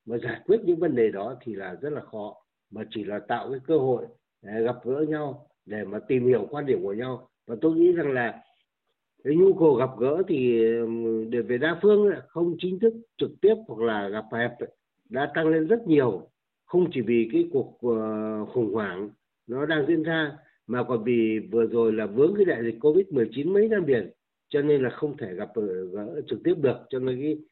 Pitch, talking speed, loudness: 150 Hz, 220 wpm, -25 LUFS